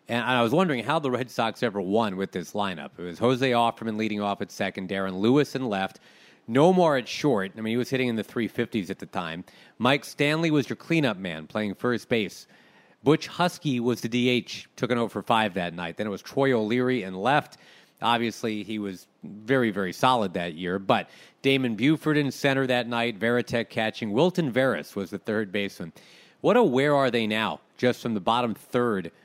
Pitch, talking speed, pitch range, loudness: 115 Hz, 210 wpm, 105-130 Hz, -26 LUFS